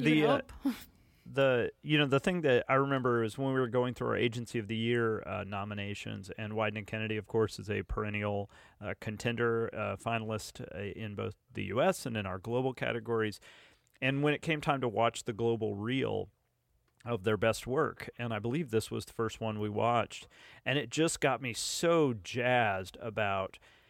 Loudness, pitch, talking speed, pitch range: -33 LUFS, 115 Hz, 195 wpm, 105-130 Hz